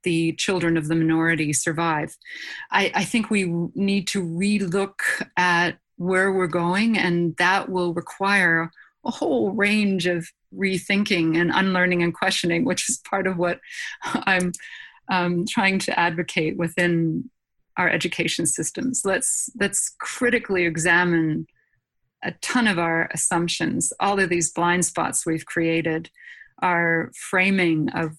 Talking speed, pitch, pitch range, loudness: 135 wpm, 180 Hz, 170-200 Hz, -22 LUFS